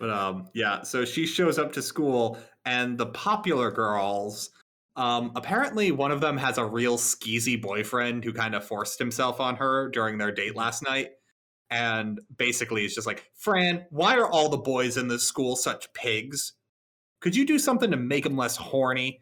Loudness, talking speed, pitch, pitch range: -26 LUFS, 185 wpm, 125 Hz, 115-145 Hz